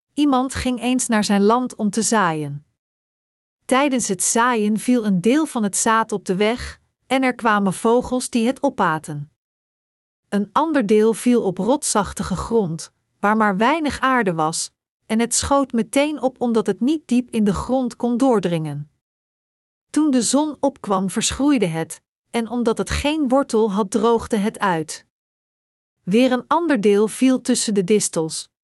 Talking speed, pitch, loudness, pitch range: 160 wpm, 230 Hz, -19 LUFS, 205-255 Hz